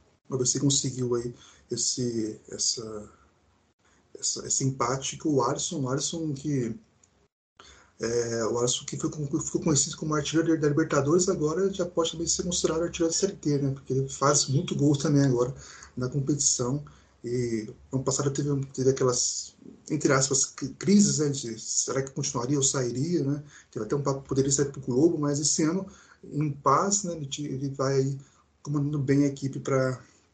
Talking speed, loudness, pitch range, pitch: 170 wpm, -27 LUFS, 130-155 Hz, 140 Hz